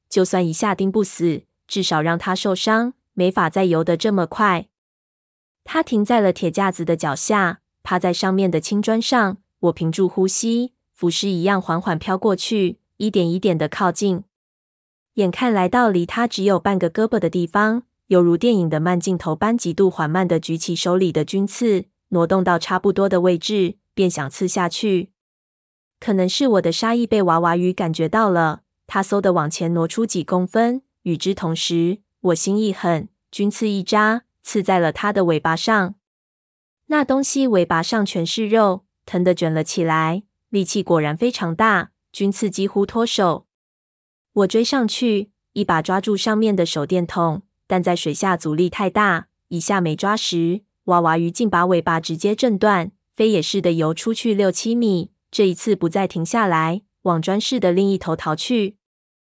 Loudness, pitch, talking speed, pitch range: -19 LUFS, 190 Hz, 250 characters per minute, 170-210 Hz